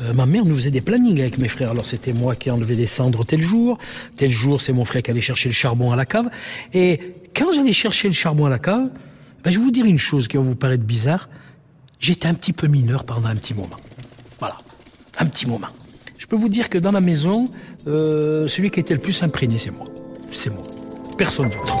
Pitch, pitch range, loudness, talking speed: 140 Hz, 125-185 Hz, -19 LUFS, 240 wpm